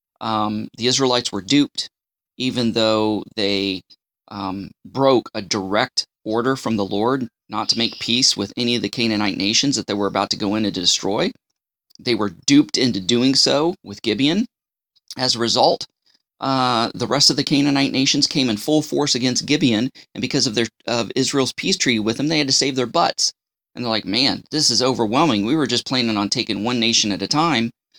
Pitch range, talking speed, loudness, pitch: 105-135 Hz, 200 wpm, -19 LUFS, 120 Hz